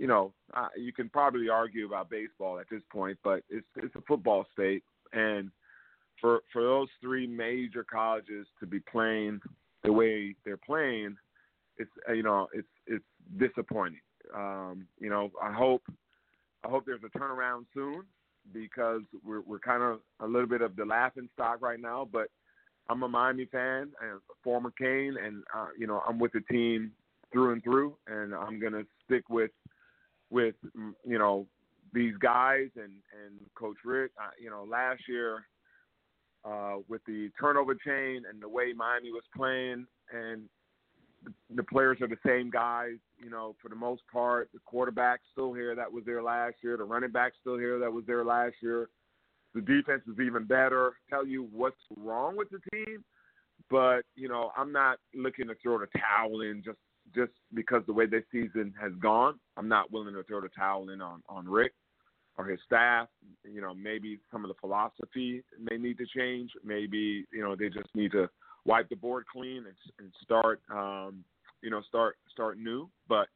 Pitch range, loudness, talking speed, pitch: 105-125 Hz, -32 LUFS, 185 wpm, 115 Hz